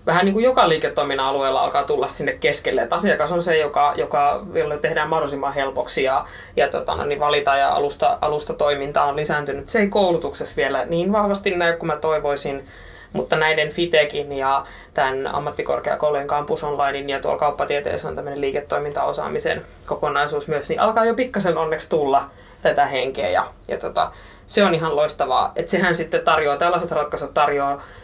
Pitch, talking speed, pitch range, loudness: 150 Hz, 165 wpm, 140-180 Hz, -20 LUFS